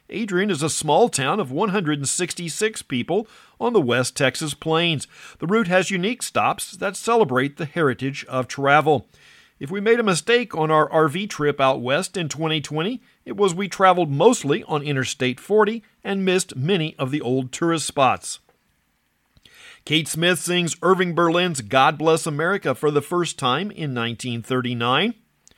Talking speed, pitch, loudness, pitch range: 155 wpm, 160 Hz, -21 LUFS, 140-190 Hz